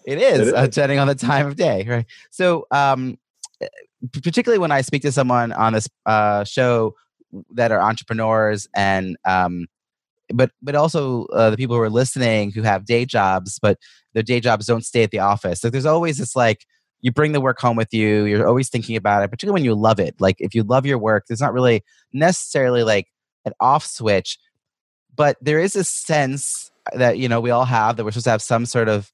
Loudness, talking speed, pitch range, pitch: -19 LUFS, 215 wpm, 110-140 Hz, 120 Hz